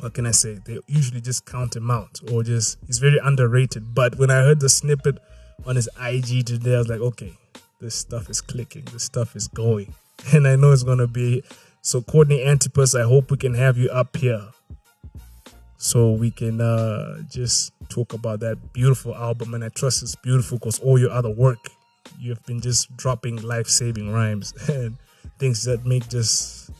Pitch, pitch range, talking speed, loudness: 120 Hz, 115-130 Hz, 190 wpm, -21 LUFS